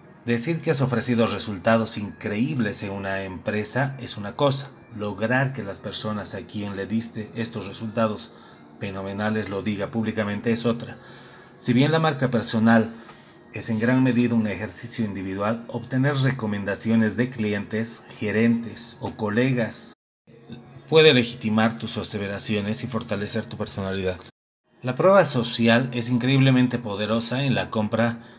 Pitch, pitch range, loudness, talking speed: 115 Hz, 105-120 Hz, -24 LUFS, 135 wpm